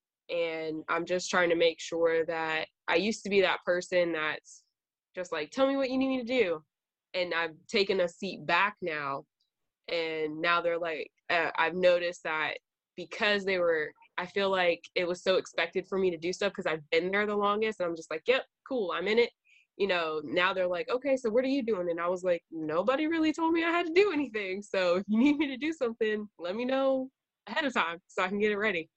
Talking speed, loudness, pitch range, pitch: 235 wpm, -30 LUFS, 170-255 Hz, 190 Hz